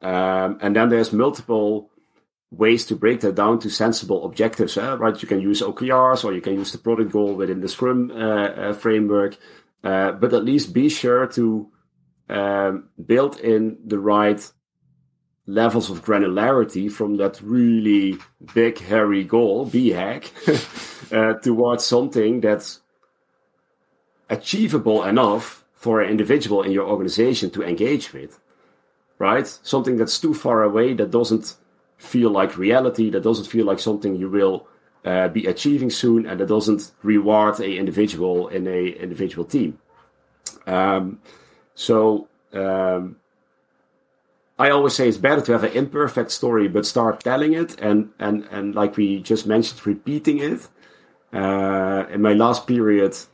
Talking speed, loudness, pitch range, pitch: 150 wpm, -20 LUFS, 100-115 Hz, 105 Hz